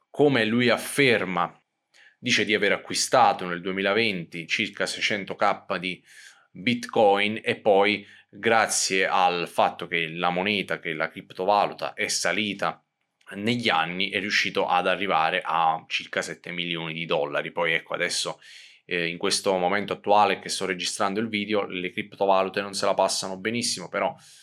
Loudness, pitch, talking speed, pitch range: -24 LUFS, 100 Hz, 145 wpm, 90-105 Hz